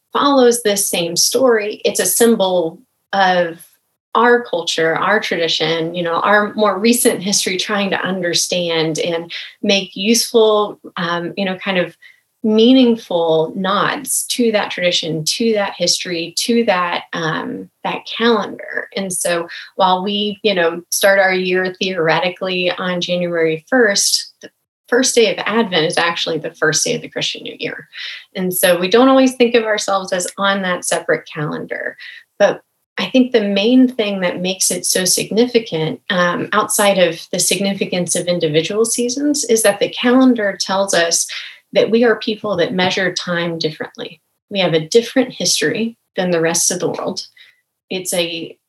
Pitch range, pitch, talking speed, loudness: 175-225 Hz, 195 Hz, 160 wpm, -16 LUFS